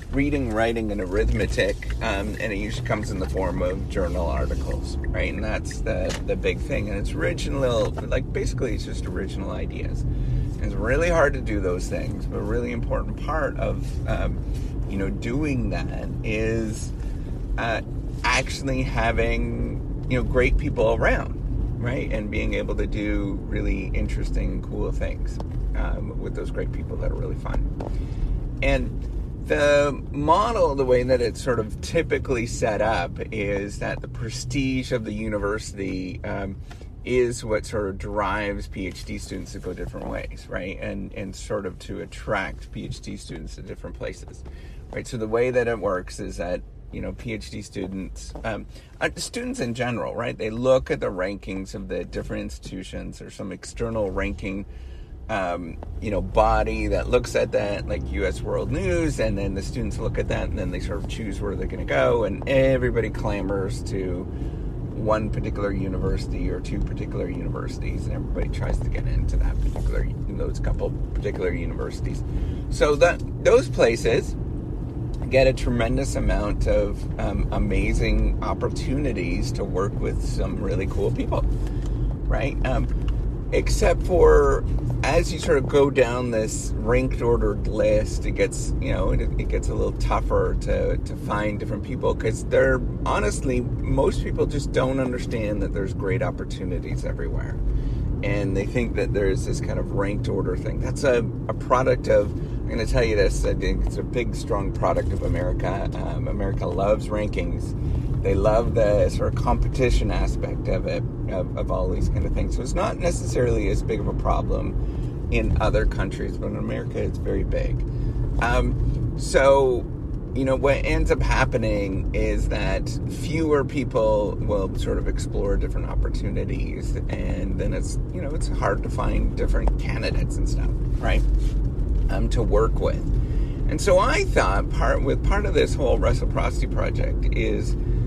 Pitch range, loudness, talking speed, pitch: 100-125 Hz, -25 LUFS, 165 wpm, 110 Hz